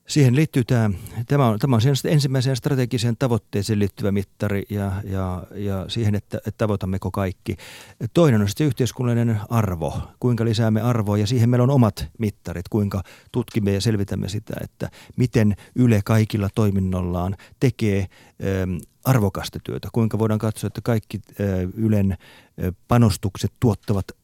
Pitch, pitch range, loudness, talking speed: 110 Hz, 100-120 Hz, -22 LUFS, 140 wpm